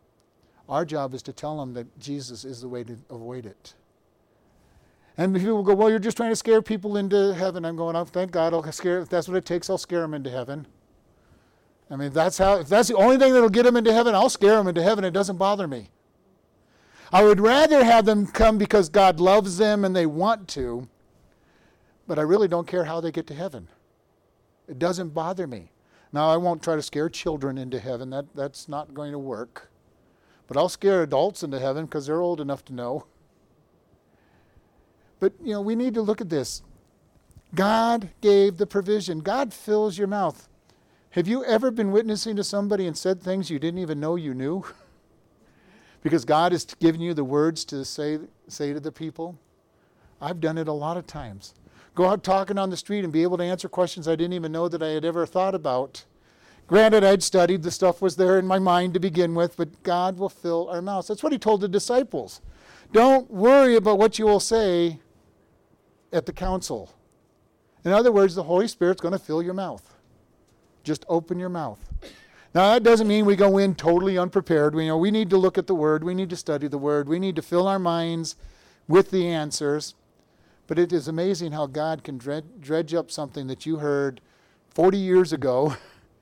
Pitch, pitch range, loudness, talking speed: 175 Hz, 150-200 Hz, -23 LUFS, 205 wpm